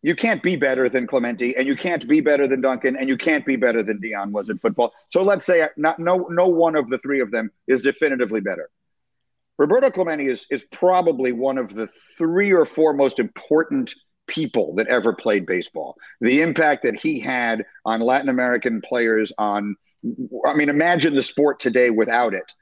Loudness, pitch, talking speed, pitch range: -20 LUFS, 140 Hz, 195 wpm, 125-170 Hz